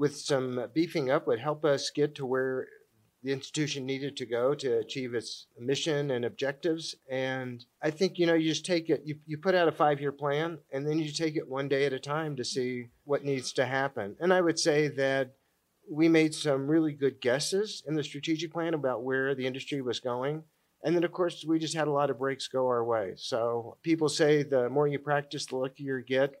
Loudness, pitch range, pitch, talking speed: -30 LUFS, 135-160 Hz, 145 Hz, 230 wpm